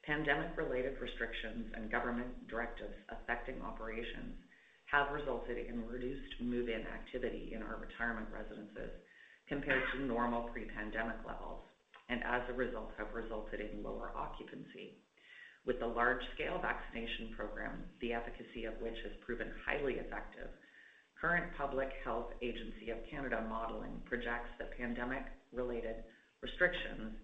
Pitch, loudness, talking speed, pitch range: 120 Hz, -41 LUFS, 130 wpm, 115-130 Hz